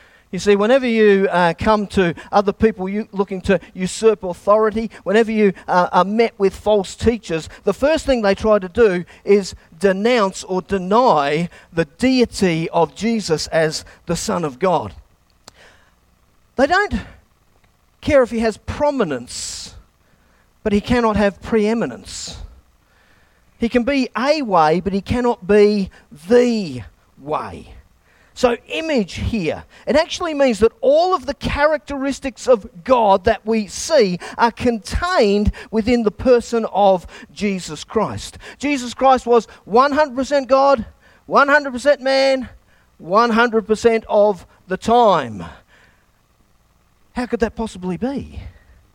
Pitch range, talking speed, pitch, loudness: 185-245 Hz, 130 wpm, 215 Hz, -17 LUFS